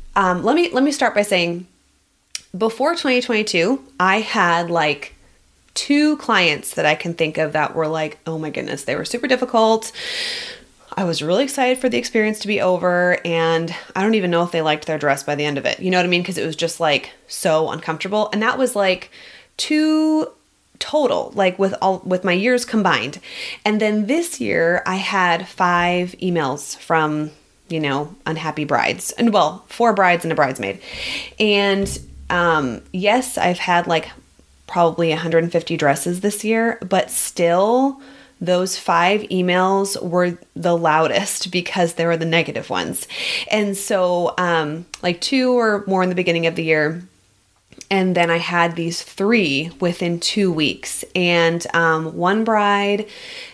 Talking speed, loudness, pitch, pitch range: 170 wpm, -19 LUFS, 180 Hz, 165-215 Hz